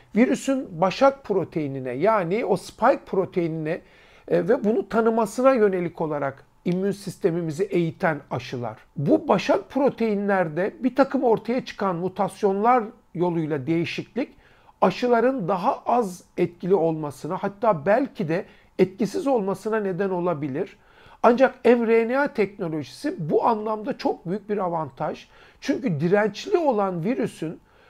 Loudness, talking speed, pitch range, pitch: -24 LUFS, 110 wpm, 175-235 Hz, 200 Hz